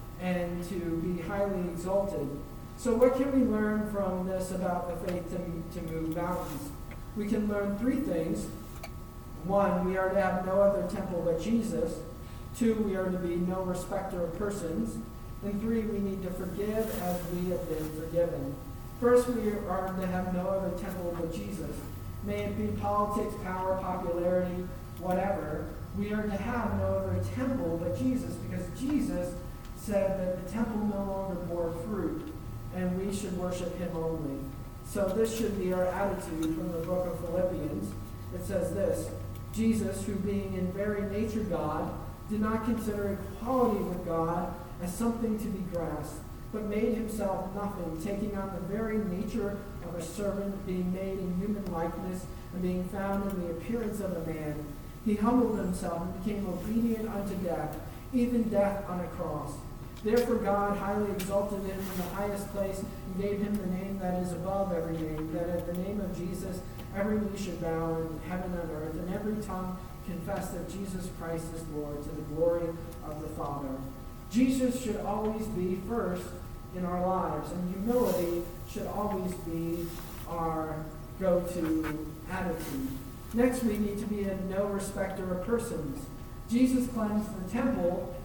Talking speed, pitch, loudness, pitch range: 165 wpm, 185 Hz, -32 LUFS, 170-205 Hz